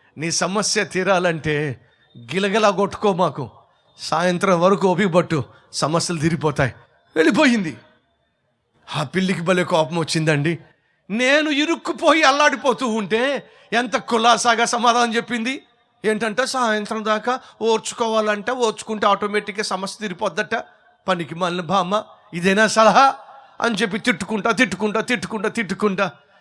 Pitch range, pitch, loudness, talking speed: 180-235 Hz, 210 Hz, -19 LUFS, 100 wpm